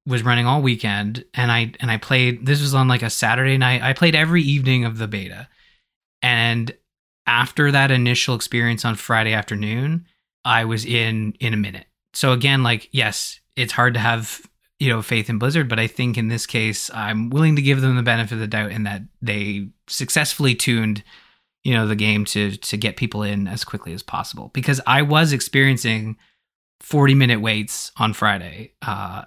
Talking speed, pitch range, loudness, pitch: 195 wpm, 110-130 Hz, -19 LUFS, 120 Hz